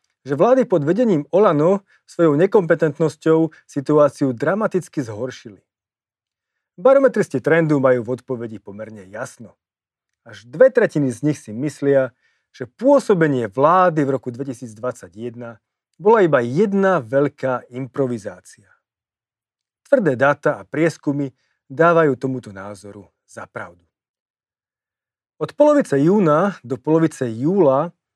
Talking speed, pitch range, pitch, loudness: 105 wpm, 125-170 Hz, 140 Hz, -18 LUFS